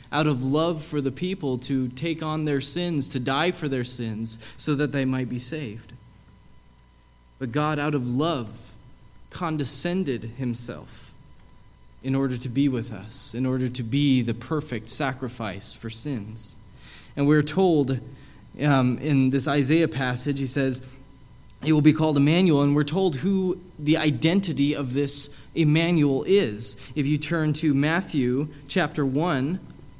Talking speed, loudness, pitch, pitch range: 150 wpm, -24 LUFS, 140 Hz, 125-150 Hz